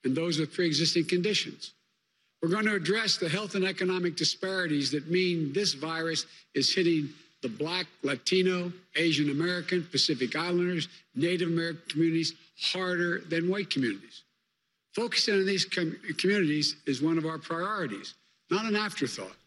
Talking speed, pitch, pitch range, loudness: 150 wpm, 170 Hz, 160-185 Hz, -29 LUFS